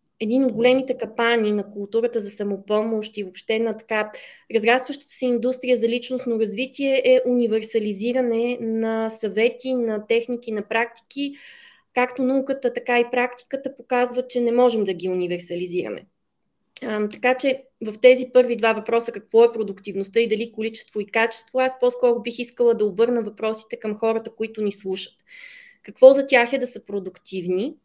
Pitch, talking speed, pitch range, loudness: 230 Hz, 155 wpm, 215-250 Hz, -22 LUFS